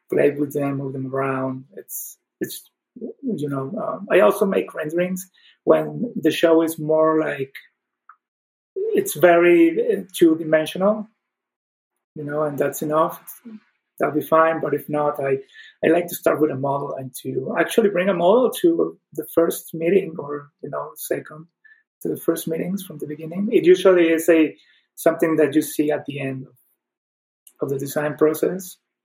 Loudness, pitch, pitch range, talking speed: -20 LUFS, 160 Hz, 145-185 Hz, 165 wpm